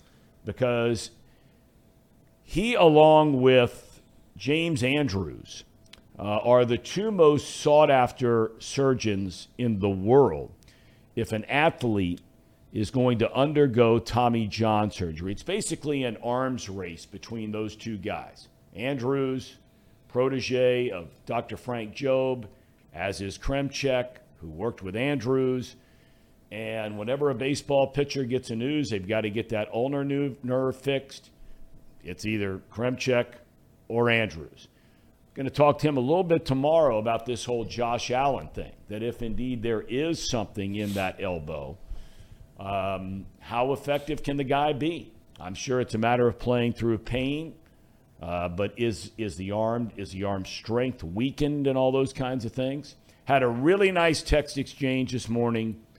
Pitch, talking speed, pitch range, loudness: 120 Hz, 145 wpm, 110-135 Hz, -26 LUFS